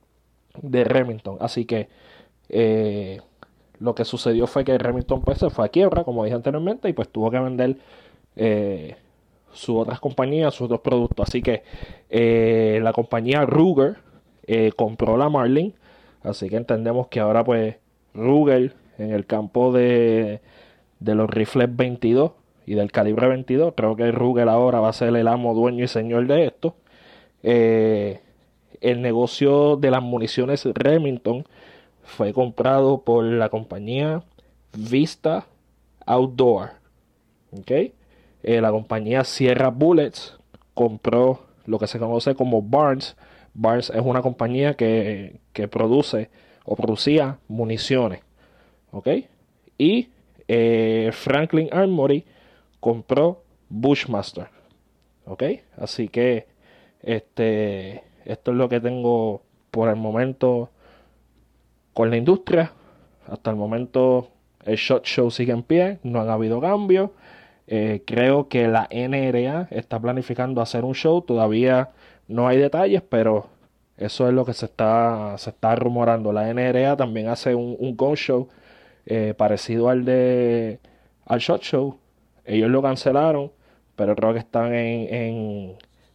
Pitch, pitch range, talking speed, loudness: 120 Hz, 110-130 Hz, 135 wpm, -21 LUFS